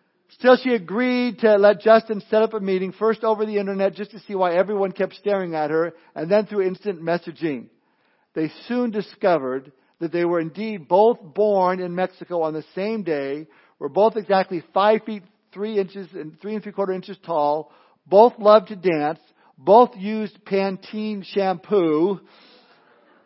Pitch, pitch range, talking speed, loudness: 195 Hz, 175-215 Hz, 170 wpm, -21 LUFS